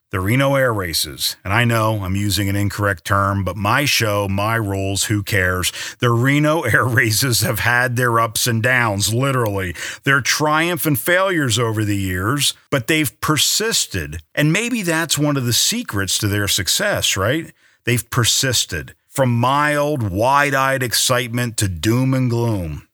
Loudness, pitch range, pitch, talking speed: -17 LUFS, 100-135 Hz, 115 Hz, 160 wpm